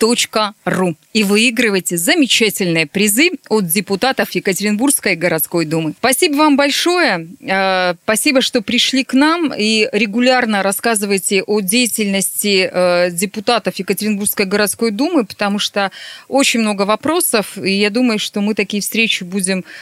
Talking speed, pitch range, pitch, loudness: 120 wpm, 195-245 Hz, 210 Hz, -14 LUFS